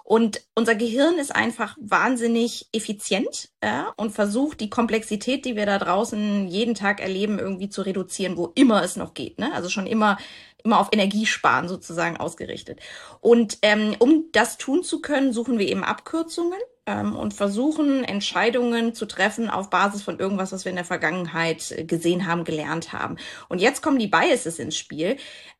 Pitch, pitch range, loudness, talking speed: 215 Hz, 190-240 Hz, -23 LUFS, 170 wpm